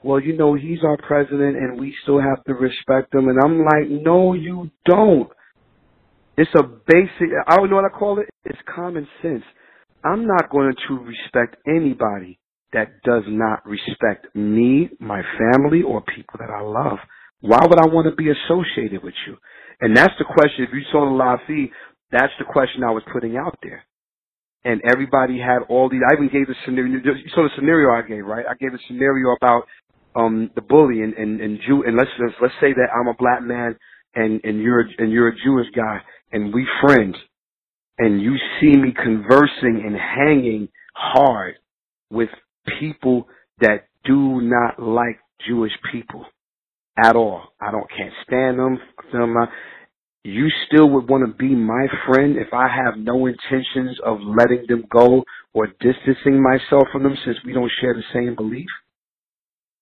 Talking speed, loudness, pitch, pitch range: 180 wpm, -18 LUFS, 130 Hz, 115-140 Hz